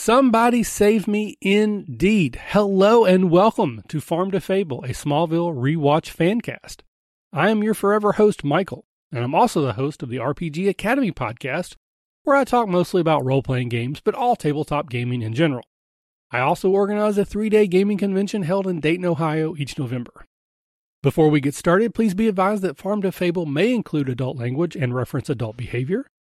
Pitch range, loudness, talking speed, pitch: 145-205 Hz, -20 LUFS, 180 wpm, 175 Hz